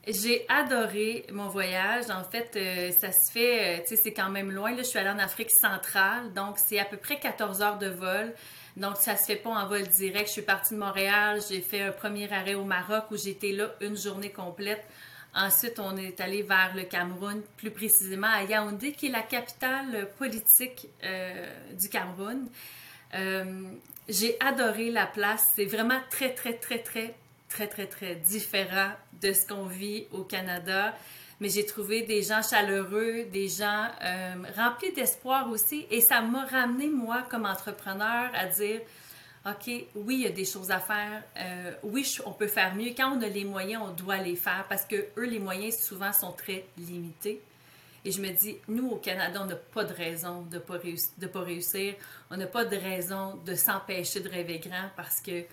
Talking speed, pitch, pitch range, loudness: 195 wpm, 205 Hz, 190-220 Hz, -28 LUFS